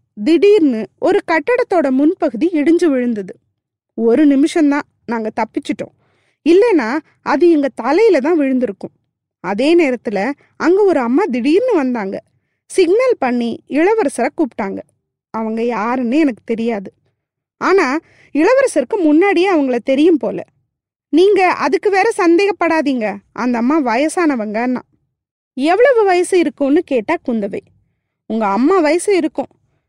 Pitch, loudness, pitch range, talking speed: 295 Hz, -15 LUFS, 235-345 Hz, 110 wpm